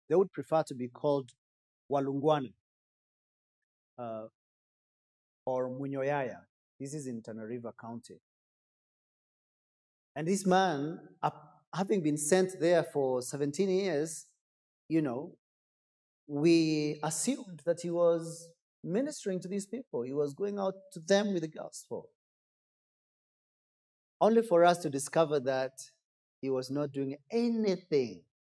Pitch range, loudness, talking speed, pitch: 135-185 Hz, -32 LUFS, 120 wpm, 150 Hz